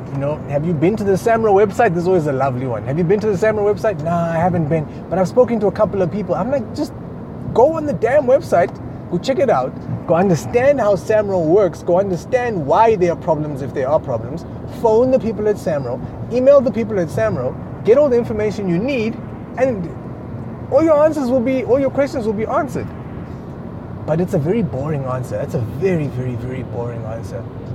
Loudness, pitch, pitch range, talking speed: -17 LUFS, 185 Hz, 150-225 Hz, 220 wpm